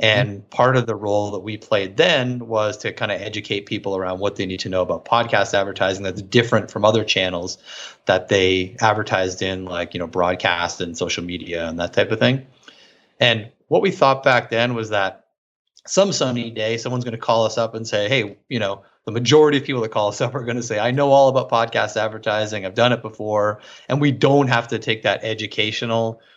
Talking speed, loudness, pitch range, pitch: 220 wpm, -20 LUFS, 100-120 Hz, 110 Hz